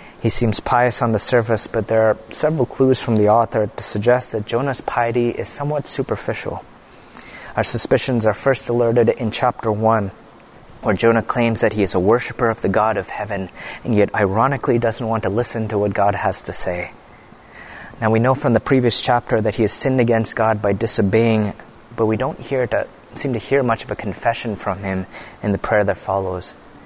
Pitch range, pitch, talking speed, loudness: 105-120 Hz, 115 Hz, 200 wpm, -19 LUFS